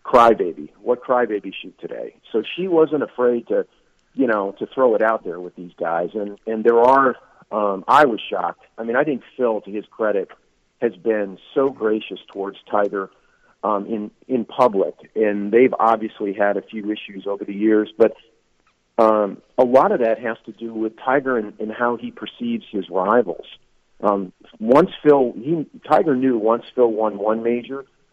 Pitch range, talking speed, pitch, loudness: 105-125 Hz, 180 wpm, 110 Hz, -20 LUFS